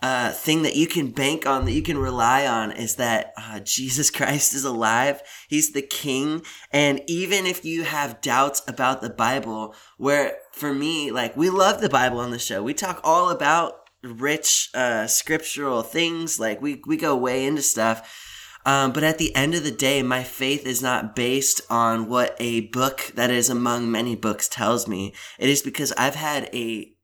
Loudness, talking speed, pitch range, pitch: -22 LUFS, 195 wpm, 120-150 Hz, 135 Hz